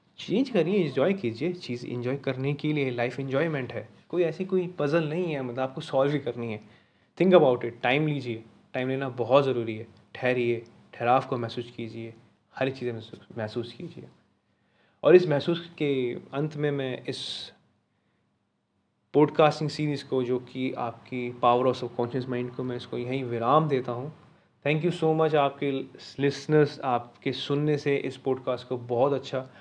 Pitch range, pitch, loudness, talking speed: 120-150 Hz, 130 Hz, -27 LUFS, 170 wpm